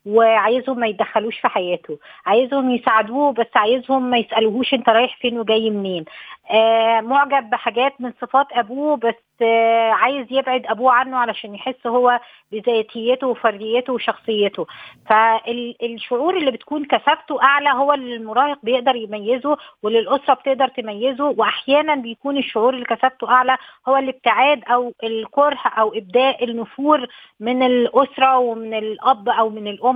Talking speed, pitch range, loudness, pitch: 130 wpm, 225-265 Hz, -18 LUFS, 245 Hz